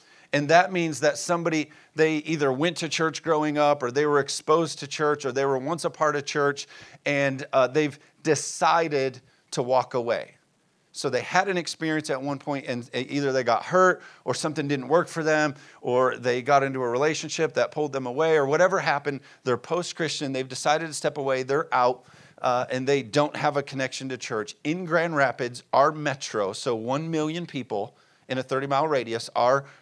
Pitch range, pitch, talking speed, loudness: 135-160 Hz, 145 Hz, 200 wpm, -25 LUFS